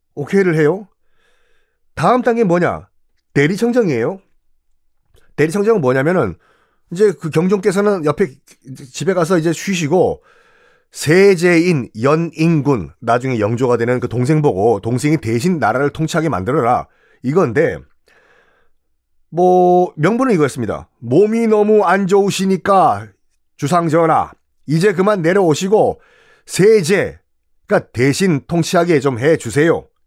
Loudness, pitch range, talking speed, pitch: -15 LUFS, 125-195 Hz, 265 characters per minute, 160 Hz